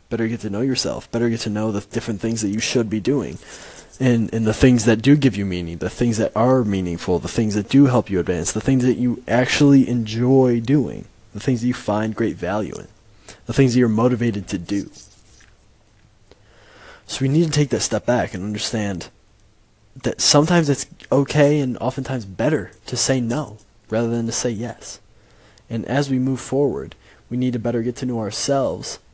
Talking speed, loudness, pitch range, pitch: 200 wpm, -20 LUFS, 105-130 Hz, 115 Hz